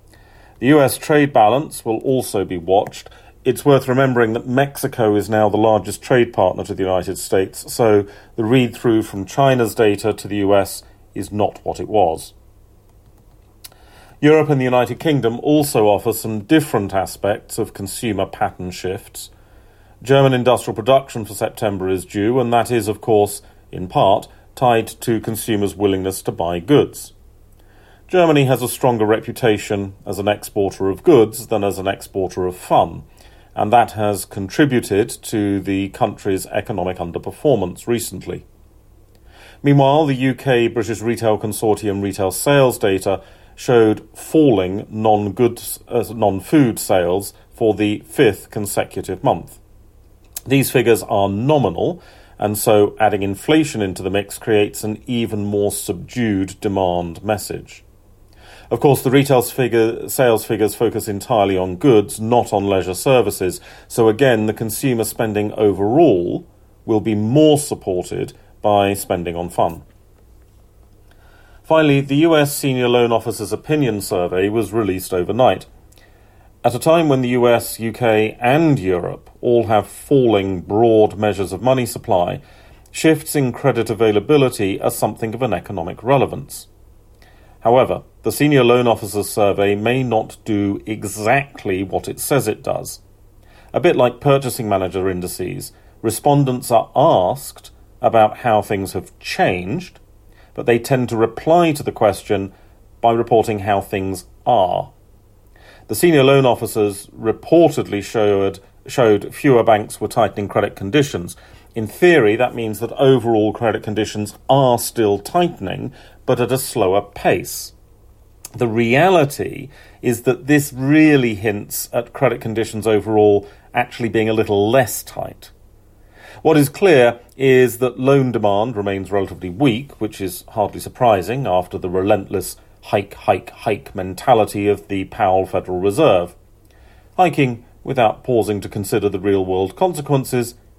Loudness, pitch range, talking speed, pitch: -17 LUFS, 100-120 Hz, 140 wpm, 105 Hz